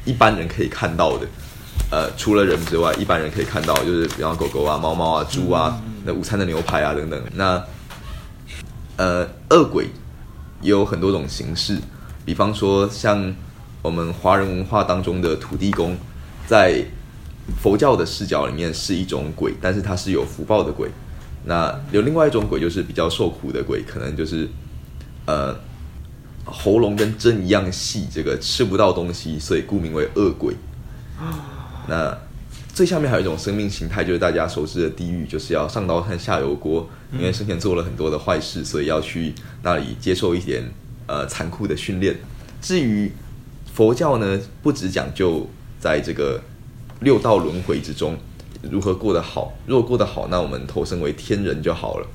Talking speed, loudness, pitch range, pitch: 260 characters per minute, -21 LUFS, 85-105 Hz, 95 Hz